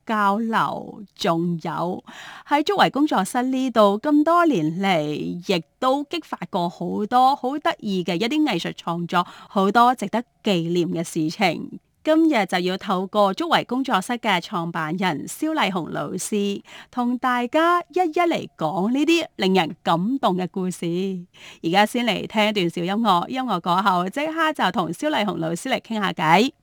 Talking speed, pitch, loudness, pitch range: 235 characters per minute, 205 Hz, -22 LUFS, 180-260 Hz